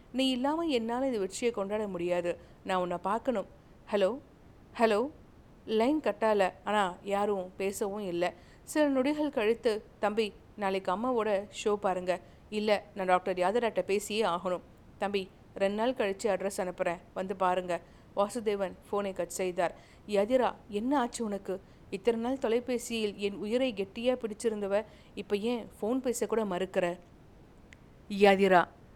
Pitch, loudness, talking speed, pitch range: 205 Hz, -31 LUFS, 125 wpm, 185-230 Hz